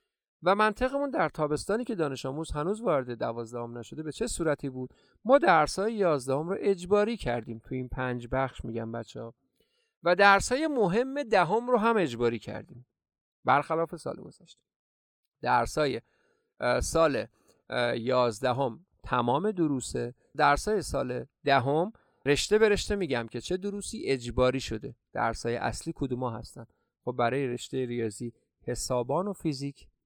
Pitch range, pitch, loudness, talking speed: 120-200 Hz, 140 Hz, -29 LUFS, 140 wpm